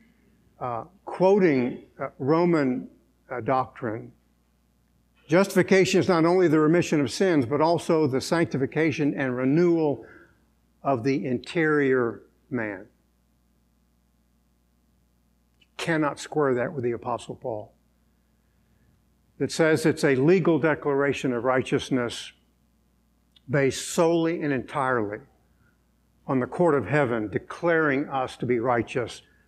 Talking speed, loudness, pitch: 105 wpm, -24 LUFS, 130 Hz